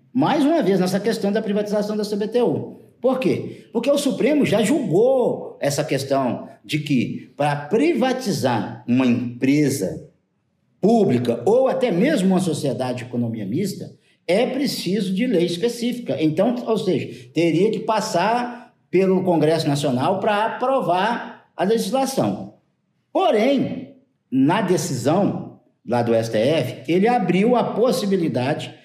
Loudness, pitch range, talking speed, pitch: -20 LUFS, 145-235 Hz, 125 wpm, 190 Hz